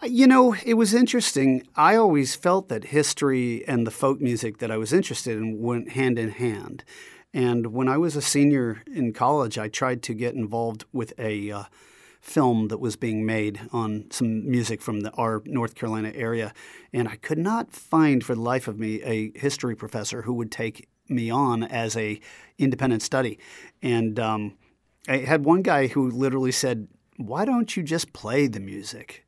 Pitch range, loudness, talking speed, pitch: 110-140 Hz, -24 LUFS, 185 wpm, 120 Hz